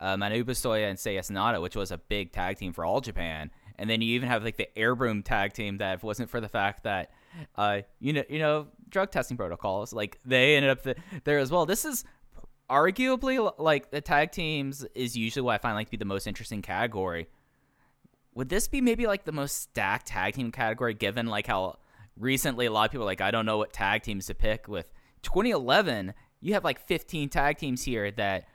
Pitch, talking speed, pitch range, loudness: 120 Hz, 225 wpm, 105-145 Hz, -29 LUFS